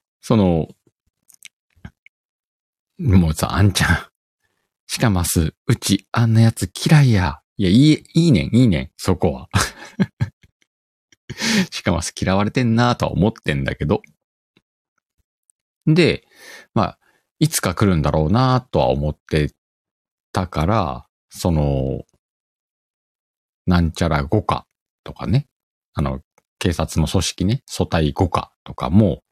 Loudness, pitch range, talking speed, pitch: -19 LUFS, 80-125 Hz, 215 characters per minute, 95 Hz